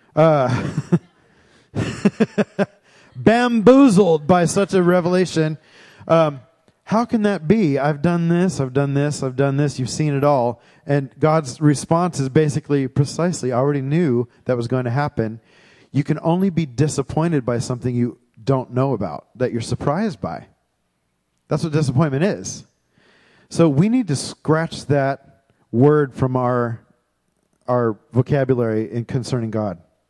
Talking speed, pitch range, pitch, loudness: 140 wpm, 125-165 Hz, 145 Hz, -19 LUFS